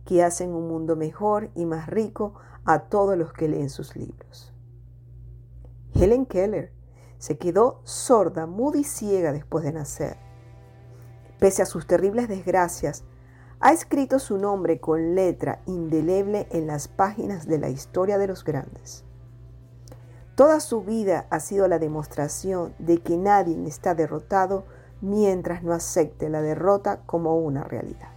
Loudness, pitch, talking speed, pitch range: -24 LUFS, 165 Hz, 145 wpm, 125-195 Hz